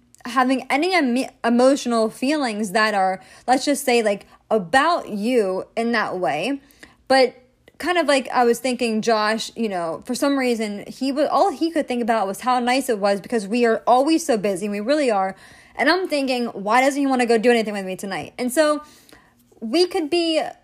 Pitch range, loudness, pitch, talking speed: 220-280 Hz, -20 LUFS, 245 Hz, 200 wpm